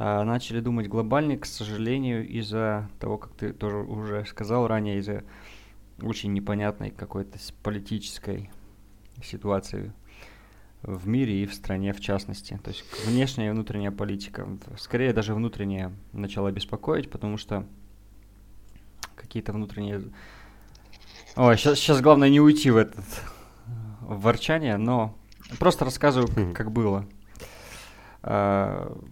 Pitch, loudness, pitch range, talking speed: 105 Hz, -26 LUFS, 100-115 Hz, 115 wpm